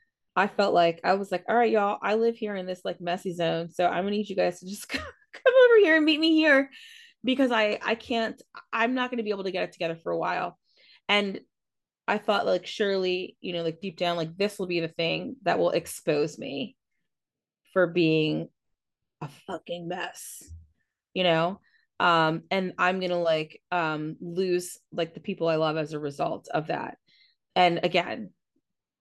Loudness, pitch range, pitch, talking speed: -26 LUFS, 170-215 Hz, 185 Hz, 200 wpm